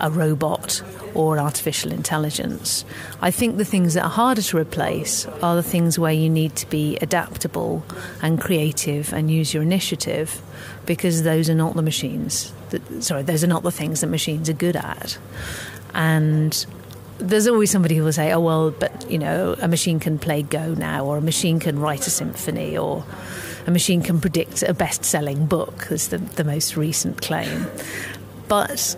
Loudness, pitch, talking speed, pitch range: -21 LUFS, 160 Hz, 180 wpm, 150-175 Hz